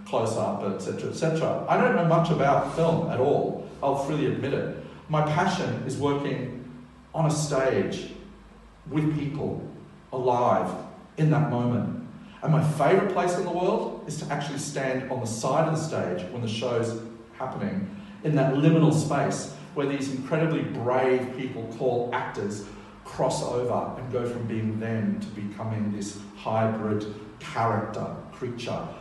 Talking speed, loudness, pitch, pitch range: 155 wpm, -27 LUFS, 130 Hz, 115-155 Hz